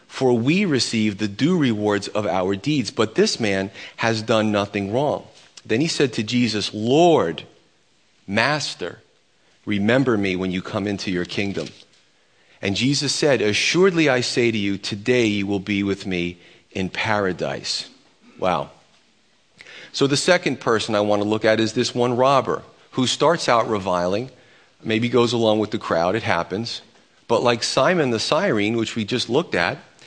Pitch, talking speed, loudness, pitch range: 110 Hz, 165 wpm, -21 LUFS, 100-125 Hz